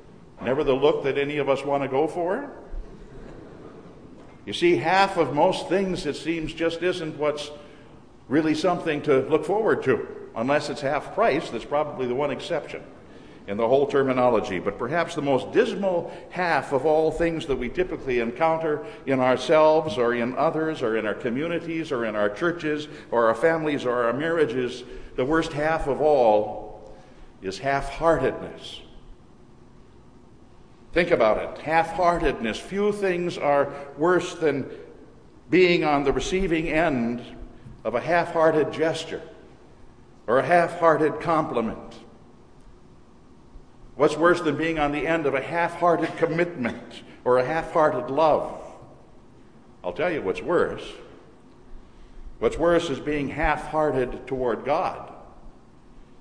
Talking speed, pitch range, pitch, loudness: 145 wpm, 130-170 Hz, 155 Hz, -24 LUFS